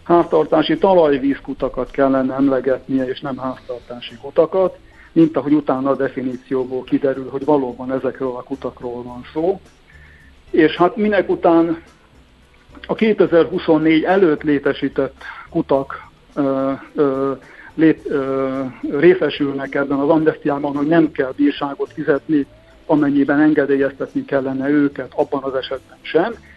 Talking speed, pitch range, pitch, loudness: 115 wpm, 130-155 Hz, 140 Hz, -18 LUFS